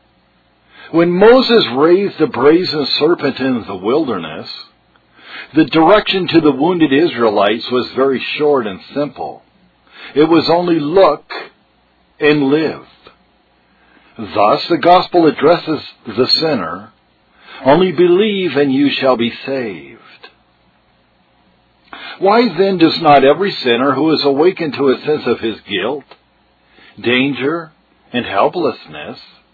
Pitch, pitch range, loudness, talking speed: 145 Hz, 125-170 Hz, -13 LUFS, 115 wpm